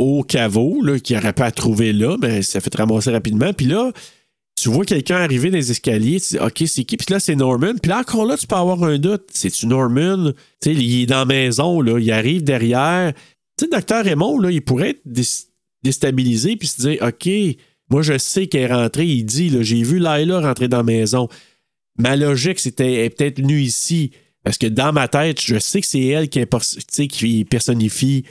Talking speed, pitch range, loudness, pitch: 235 wpm, 120-165 Hz, -17 LUFS, 135 Hz